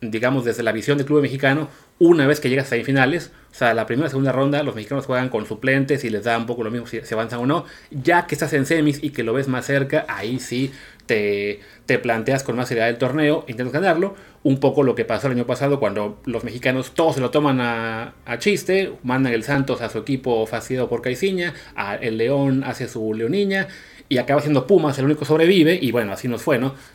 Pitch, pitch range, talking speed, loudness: 130 Hz, 120-145 Hz, 235 wpm, -20 LUFS